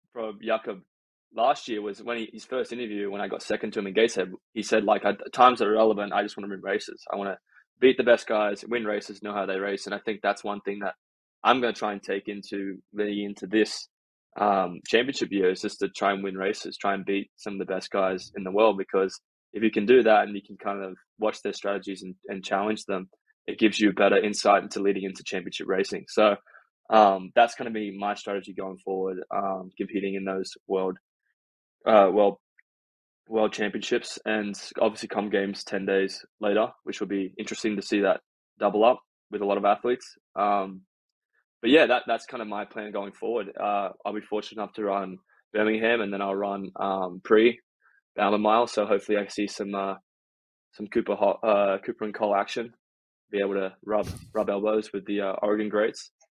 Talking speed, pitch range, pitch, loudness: 220 wpm, 95-105 Hz, 100 Hz, -26 LUFS